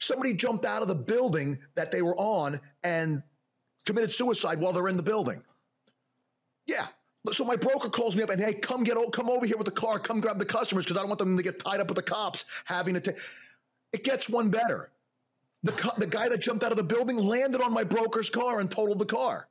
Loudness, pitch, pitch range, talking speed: -29 LUFS, 215 Hz, 185-235 Hz, 235 wpm